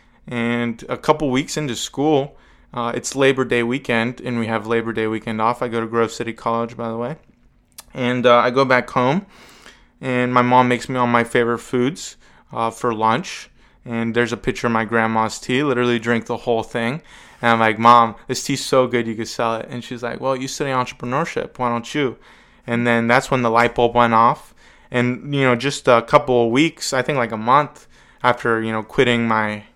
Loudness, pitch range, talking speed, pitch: -19 LUFS, 115-125 Hz, 215 wpm, 120 Hz